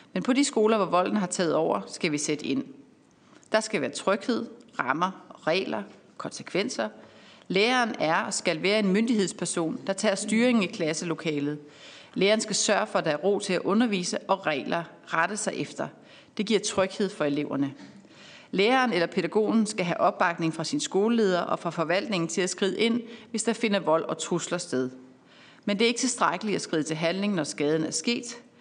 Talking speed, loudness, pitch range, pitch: 185 wpm, -26 LUFS, 165-215 Hz, 195 Hz